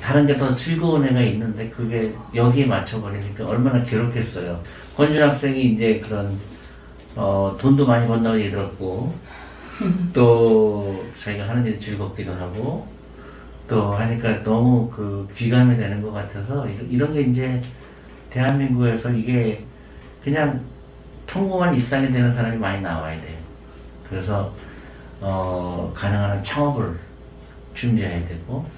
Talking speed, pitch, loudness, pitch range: 270 characters per minute, 110 Hz, -21 LUFS, 100-125 Hz